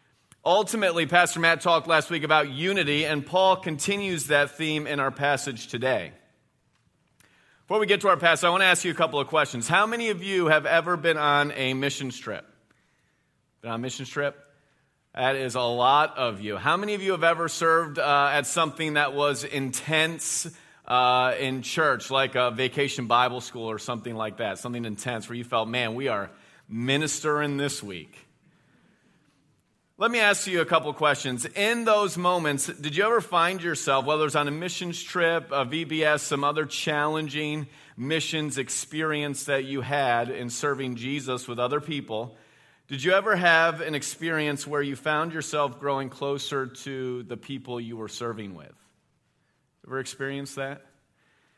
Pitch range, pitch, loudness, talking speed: 130-165 Hz, 145 Hz, -25 LUFS, 175 wpm